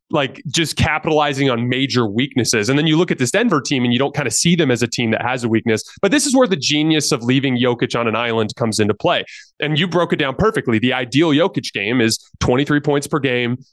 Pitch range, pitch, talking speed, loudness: 120-150 Hz, 130 Hz, 255 wpm, -17 LUFS